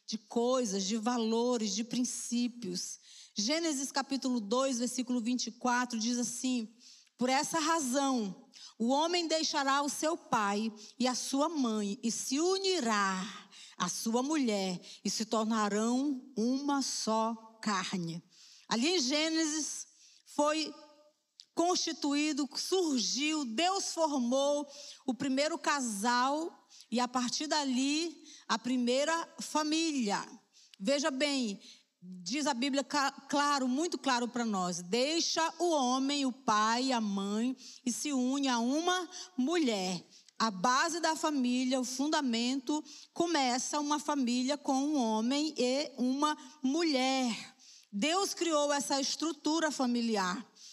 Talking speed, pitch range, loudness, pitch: 115 wpm, 235-300 Hz, -32 LUFS, 260 Hz